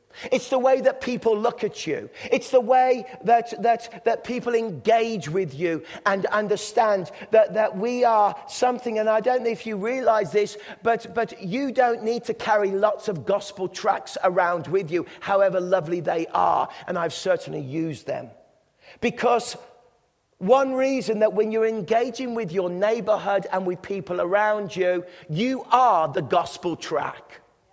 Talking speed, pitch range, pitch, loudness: 165 wpm, 190-235 Hz, 215 Hz, -23 LUFS